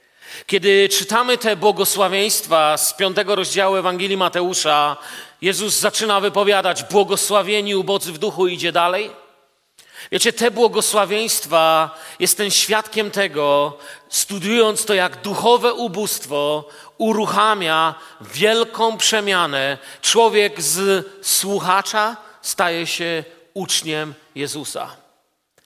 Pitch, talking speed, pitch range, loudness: 195 Hz, 90 wpm, 165-210 Hz, -17 LUFS